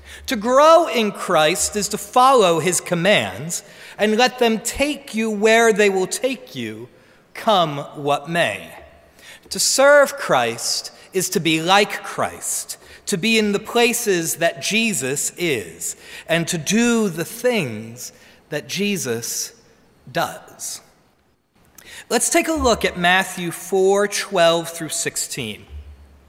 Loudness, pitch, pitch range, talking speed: -18 LUFS, 195 Hz, 160-225 Hz, 125 wpm